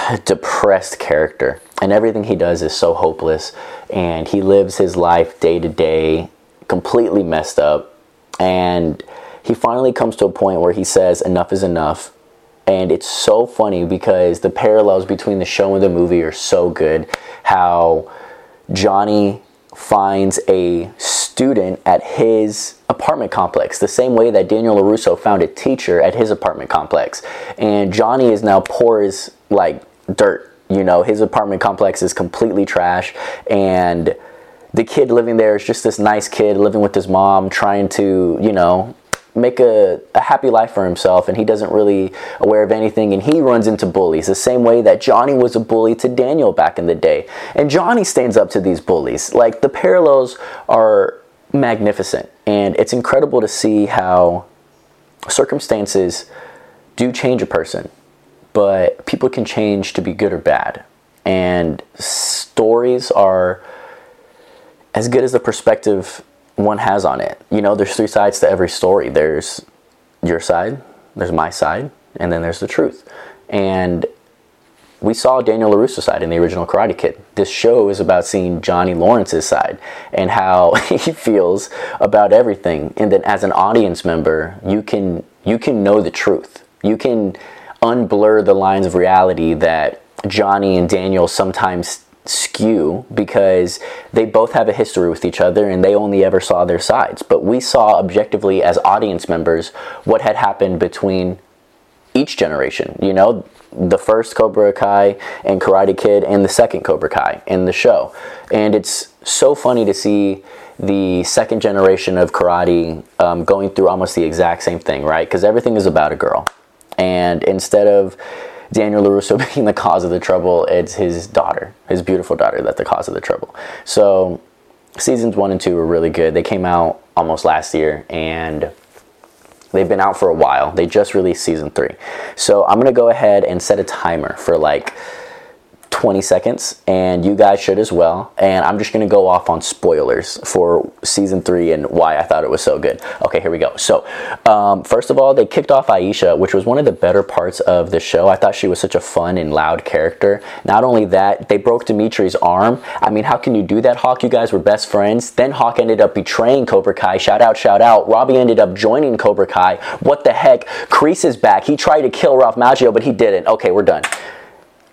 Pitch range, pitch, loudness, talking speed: 90-125 Hz, 100 Hz, -14 LUFS, 180 wpm